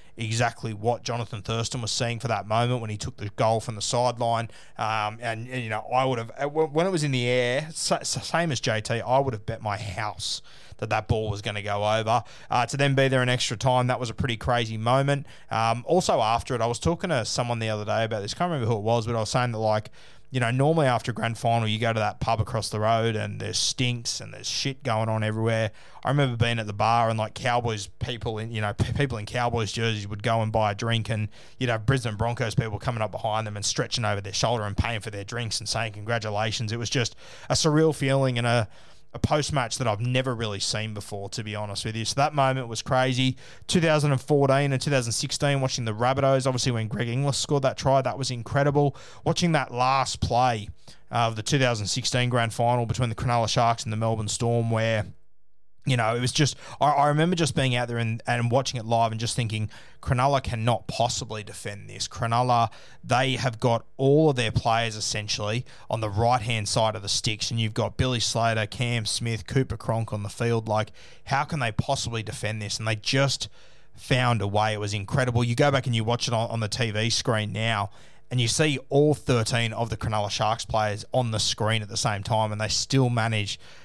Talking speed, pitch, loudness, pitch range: 230 wpm, 115 Hz, -25 LUFS, 110-130 Hz